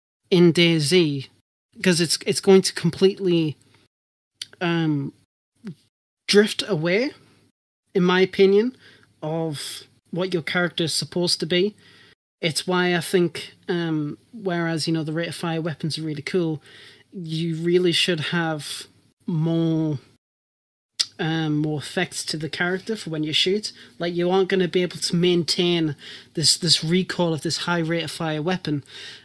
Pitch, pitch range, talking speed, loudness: 170 Hz, 155-180 Hz, 145 wpm, -22 LUFS